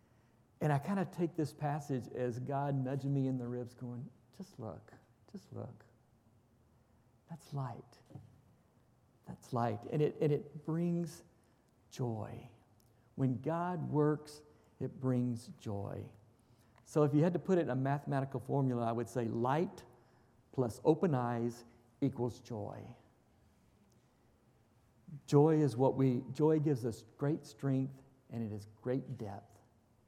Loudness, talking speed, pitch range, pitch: -36 LUFS, 140 wpm, 120-145 Hz, 125 Hz